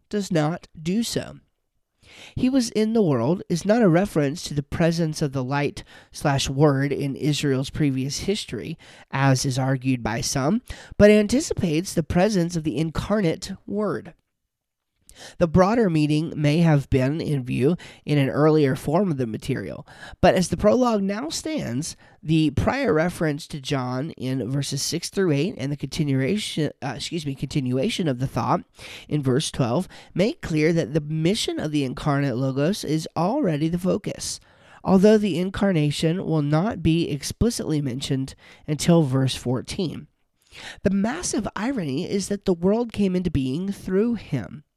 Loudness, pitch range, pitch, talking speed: -23 LUFS, 140-190 Hz, 155 Hz, 160 wpm